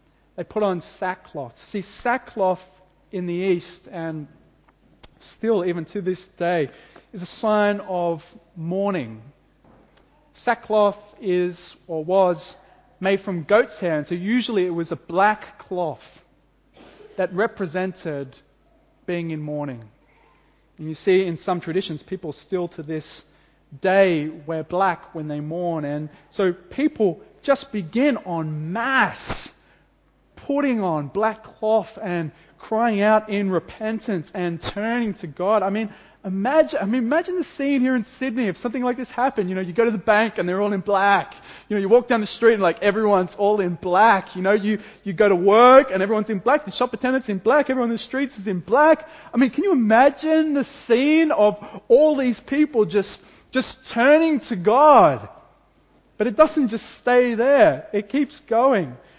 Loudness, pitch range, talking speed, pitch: -21 LUFS, 175-235 Hz, 170 wpm, 200 Hz